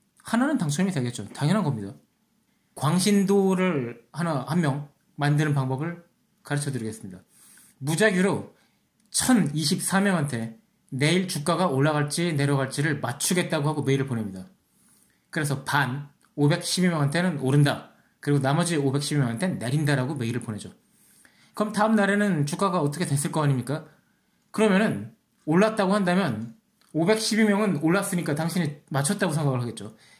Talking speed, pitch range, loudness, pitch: 310 characters per minute, 135-190 Hz, -25 LUFS, 155 Hz